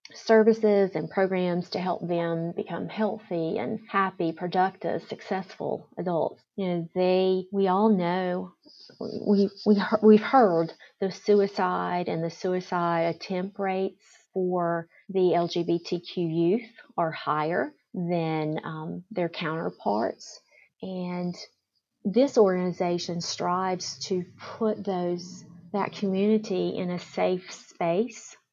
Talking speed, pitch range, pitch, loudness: 110 wpm, 170-205 Hz, 185 Hz, -27 LUFS